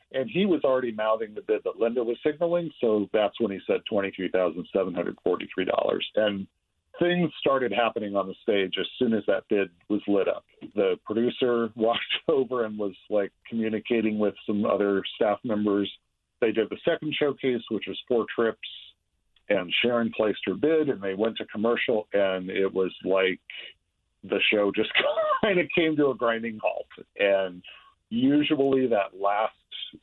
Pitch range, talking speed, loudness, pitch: 100-135 Hz, 165 wpm, -26 LUFS, 110 Hz